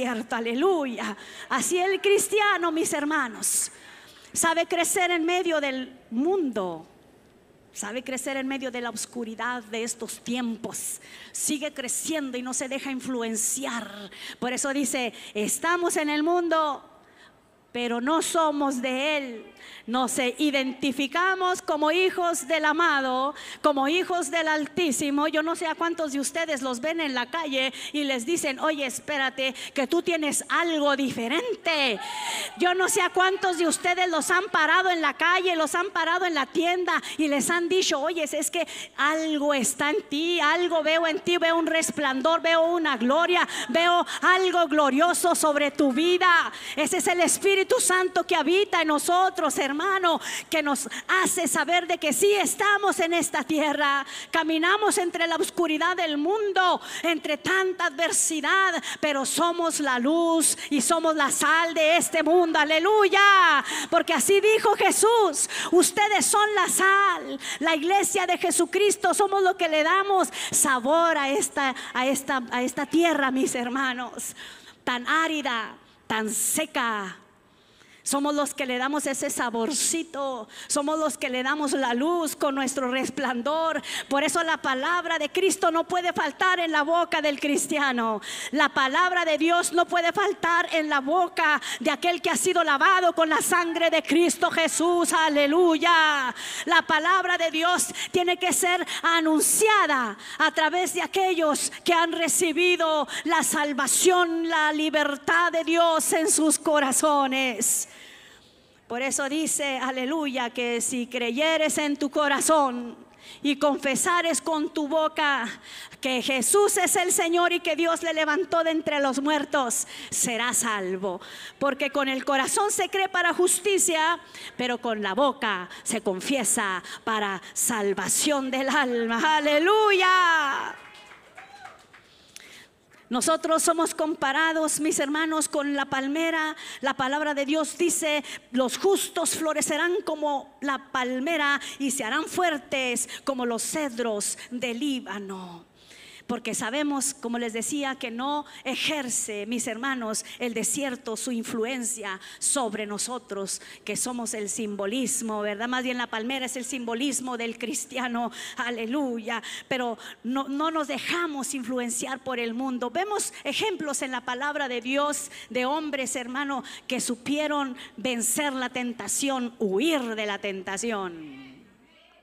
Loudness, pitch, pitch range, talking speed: -24 LUFS, 300 Hz, 260-340 Hz, 145 wpm